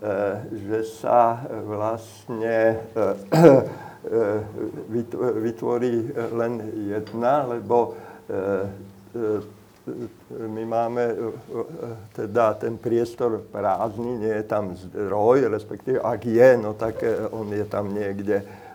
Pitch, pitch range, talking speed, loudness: 110 Hz, 105-115 Hz, 85 wpm, -23 LUFS